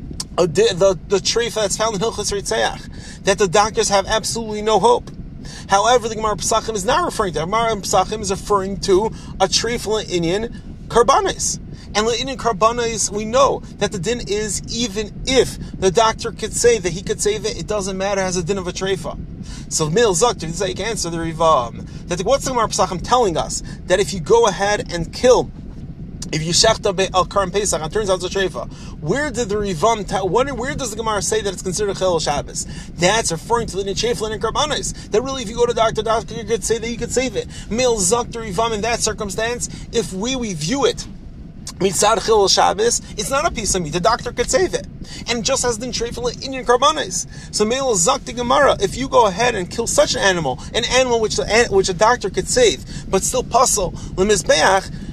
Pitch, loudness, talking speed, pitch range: 215 Hz, -18 LUFS, 210 wpm, 190-230 Hz